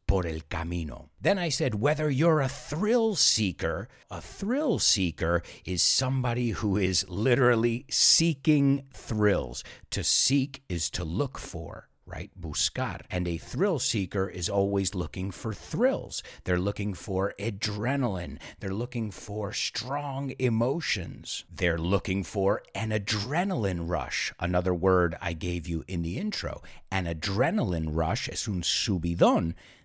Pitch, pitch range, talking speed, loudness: 100 Hz, 85-125 Hz, 135 wpm, -28 LUFS